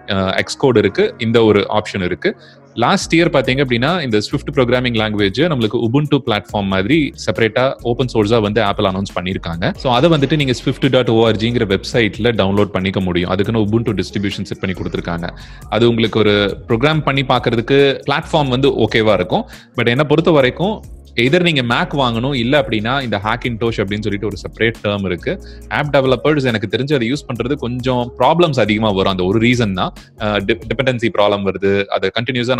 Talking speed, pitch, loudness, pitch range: 145 wpm, 115 Hz, -16 LUFS, 105-130 Hz